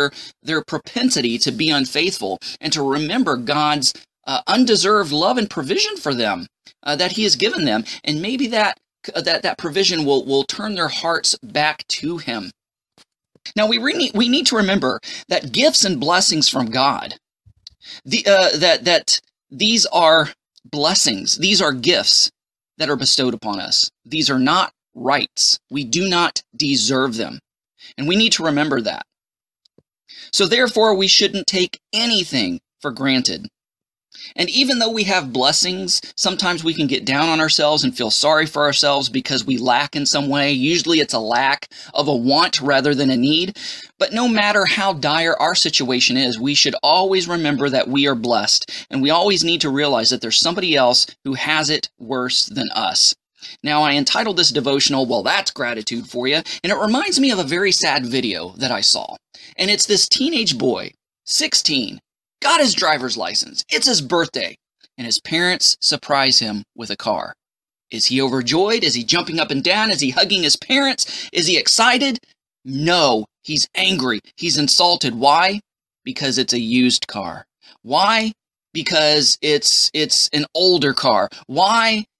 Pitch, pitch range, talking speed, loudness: 160 Hz, 140-205 Hz, 170 wpm, -16 LUFS